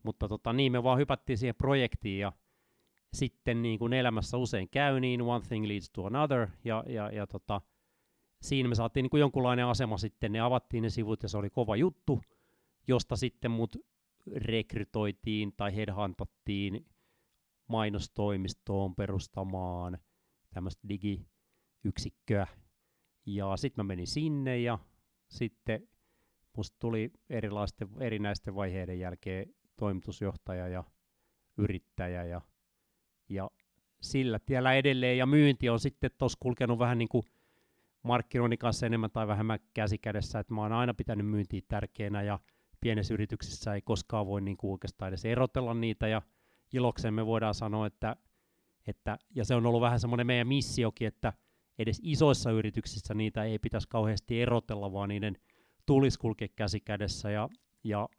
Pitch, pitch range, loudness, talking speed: 110 Hz, 100-120 Hz, -33 LUFS, 140 wpm